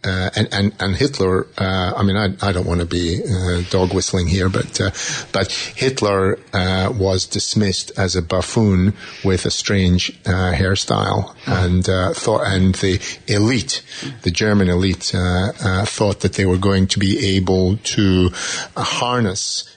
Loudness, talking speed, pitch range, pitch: -18 LUFS, 165 wpm, 90-100 Hz, 95 Hz